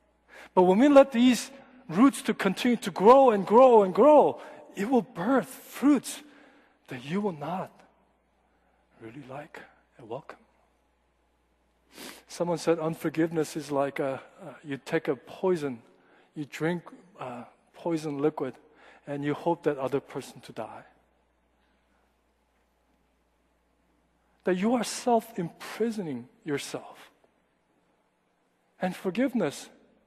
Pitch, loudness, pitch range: 180 Hz, -25 LUFS, 145-235 Hz